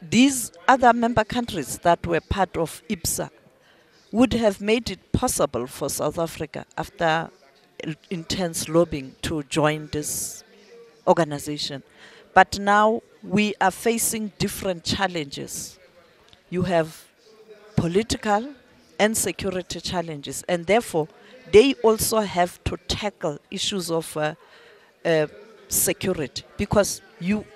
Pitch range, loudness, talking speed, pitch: 165-215 Hz, -23 LUFS, 110 wpm, 190 Hz